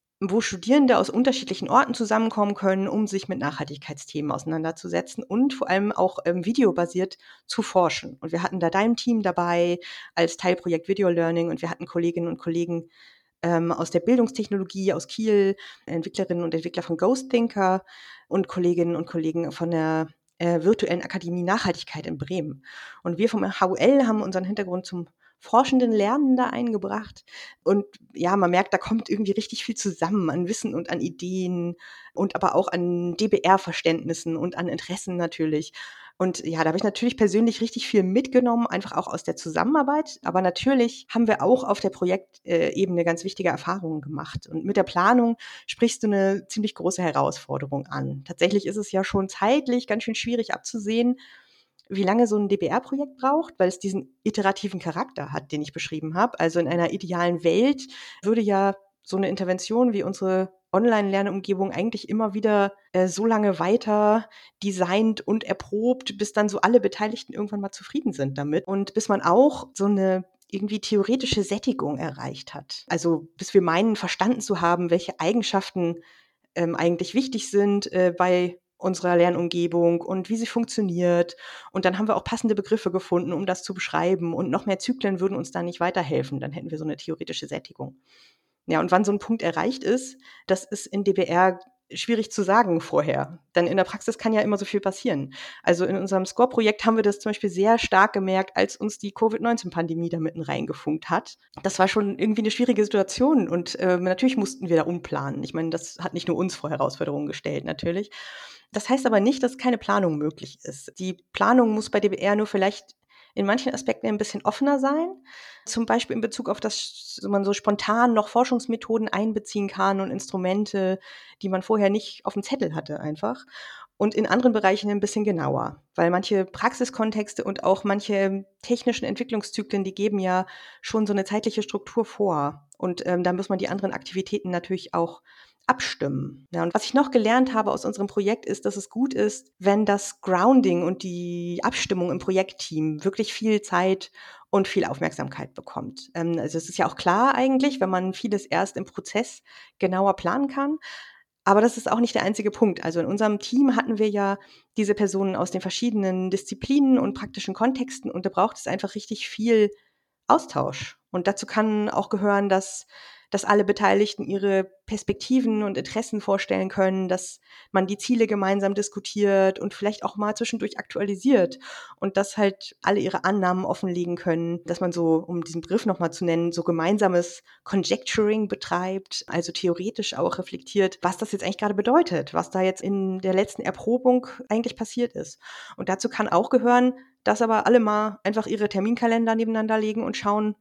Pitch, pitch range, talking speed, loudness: 195 Hz, 180-220 Hz, 180 wpm, -24 LUFS